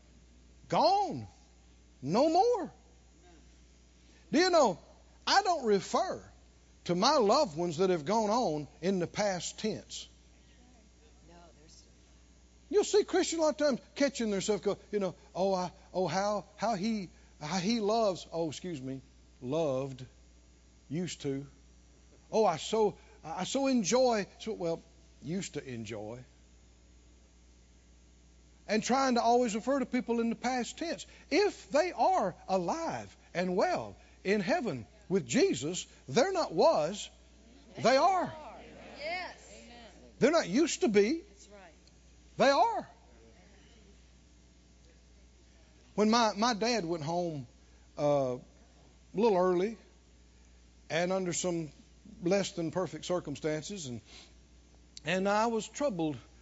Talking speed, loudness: 120 wpm, -31 LUFS